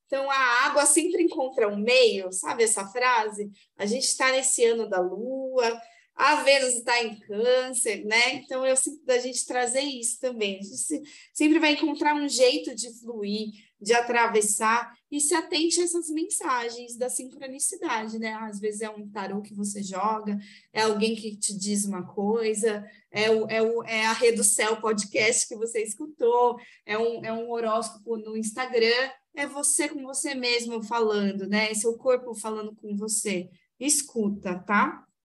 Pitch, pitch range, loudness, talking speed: 235 Hz, 215-265 Hz, -25 LUFS, 170 wpm